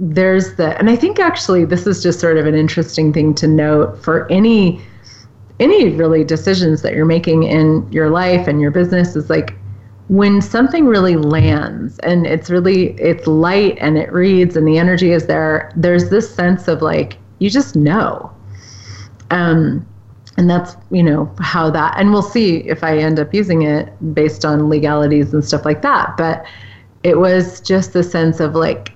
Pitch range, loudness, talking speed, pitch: 150-180 Hz, -13 LUFS, 180 wpm, 160 Hz